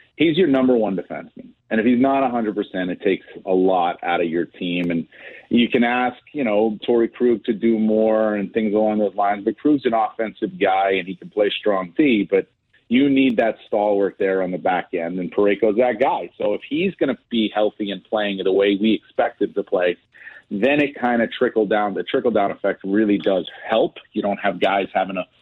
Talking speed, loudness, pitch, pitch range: 220 wpm, -20 LUFS, 105 Hz, 100-120 Hz